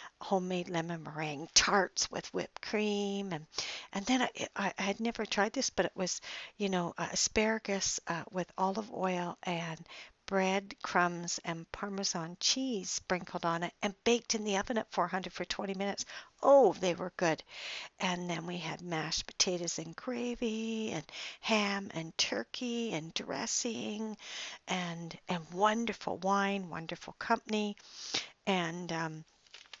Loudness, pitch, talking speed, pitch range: -34 LUFS, 190 Hz, 145 wpm, 175-215 Hz